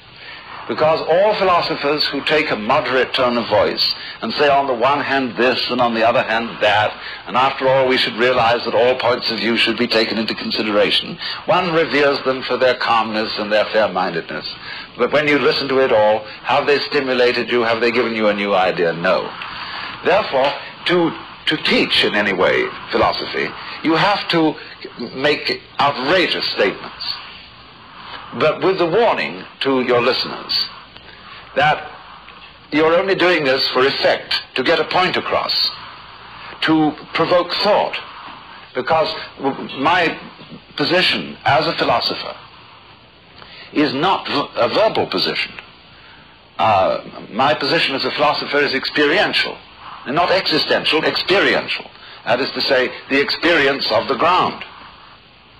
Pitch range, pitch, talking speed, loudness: 120-155 Hz, 135 Hz, 145 wpm, -17 LUFS